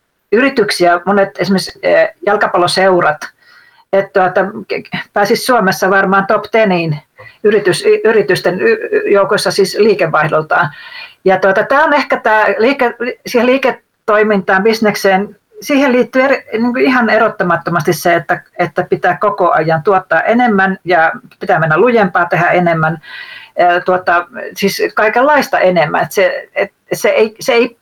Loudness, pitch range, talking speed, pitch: -12 LUFS, 185-245 Hz, 125 wpm, 205 Hz